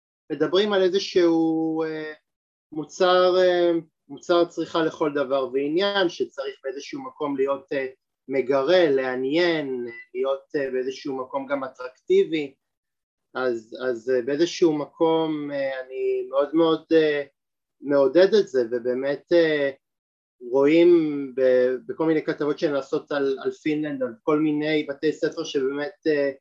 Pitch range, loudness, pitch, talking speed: 135-170 Hz, -23 LUFS, 150 Hz, 100 wpm